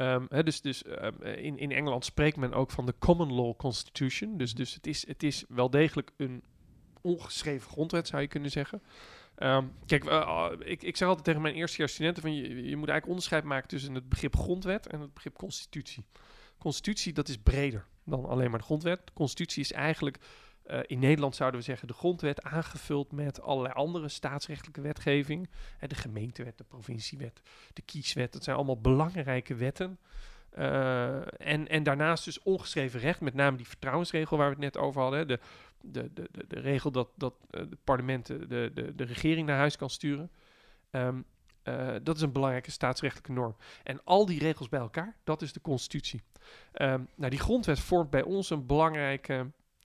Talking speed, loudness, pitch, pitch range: 195 wpm, -32 LUFS, 145 Hz, 130-155 Hz